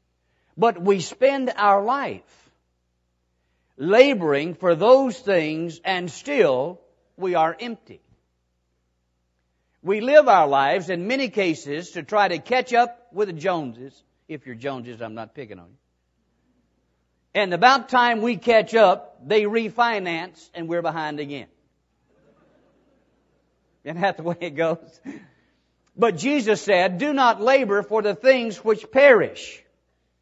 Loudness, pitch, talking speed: -20 LUFS, 175 Hz, 130 wpm